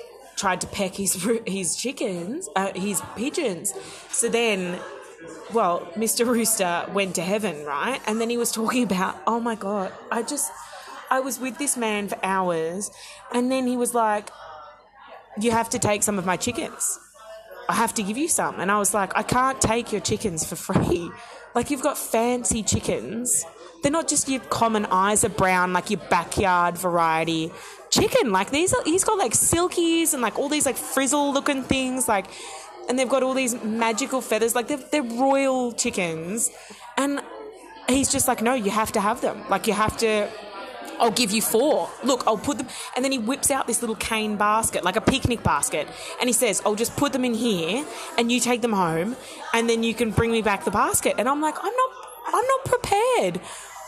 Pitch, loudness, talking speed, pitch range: 230 Hz, -23 LUFS, 200 wpm, 205-265 Hz